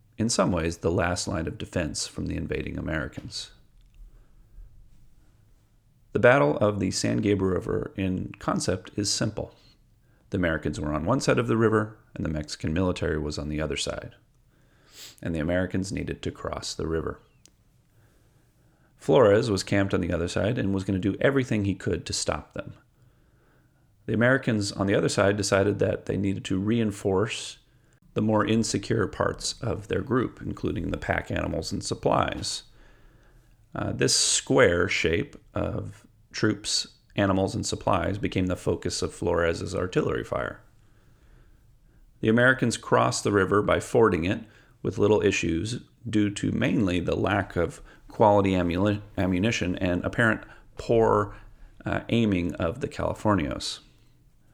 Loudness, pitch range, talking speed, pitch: -26 LUFS, 90-110 Hz, 150 wpm, 100 Hz